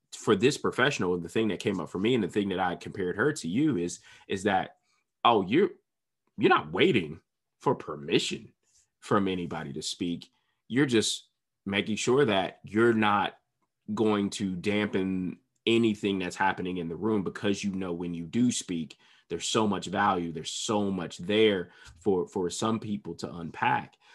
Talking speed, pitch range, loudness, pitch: 175 wpm, 85-105 Hz, -28 LUFS, 100 Hz